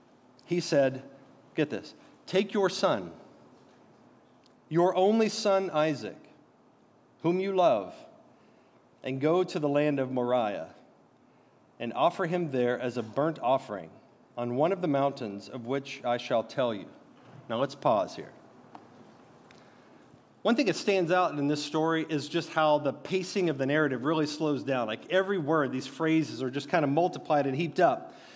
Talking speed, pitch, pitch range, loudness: 160 wpm, 150 Hz, 135-180 Hz, -29 LUFS